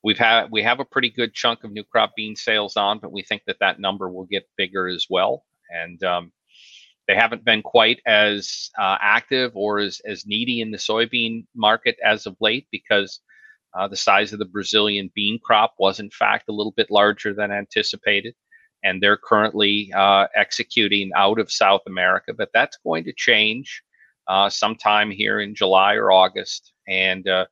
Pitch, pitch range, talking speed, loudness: 105 Hz, 95-110 Hz, 190 wpm, -19 LUFS